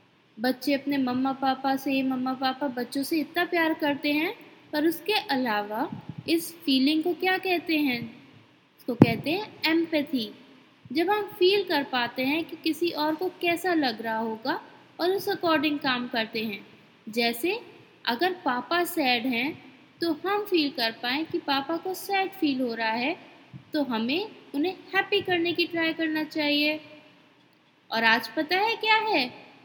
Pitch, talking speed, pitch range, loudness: 310 Hz, 160 wpm, 265-345 Hz, -26 LUFS